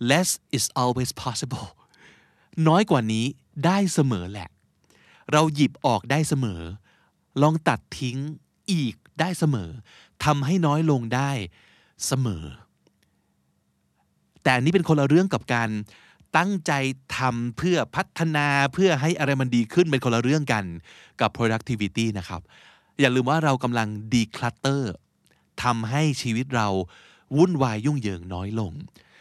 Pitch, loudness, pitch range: 130 Hz, -24 LUFS, 110-150 Hz